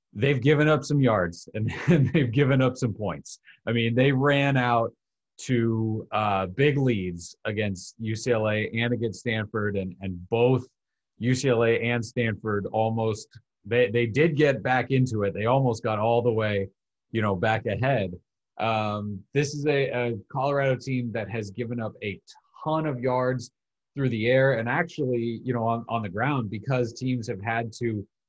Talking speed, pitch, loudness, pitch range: 170 wpm, 120 Hz, -26 LUFS, 110-130 Hz